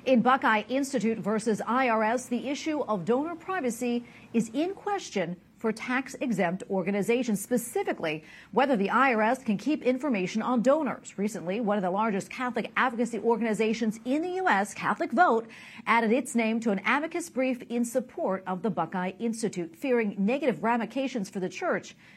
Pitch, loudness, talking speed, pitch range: 235 Hz, -28 LUFS, 155 wpm, 210-260 Hz